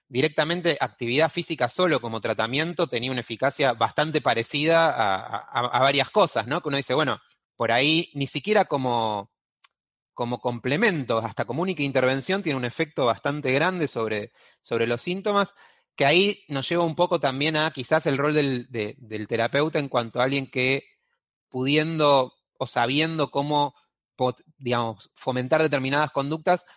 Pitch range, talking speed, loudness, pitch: 120-160 Hz, 155 wpm, -24 LUFS, 140 Hz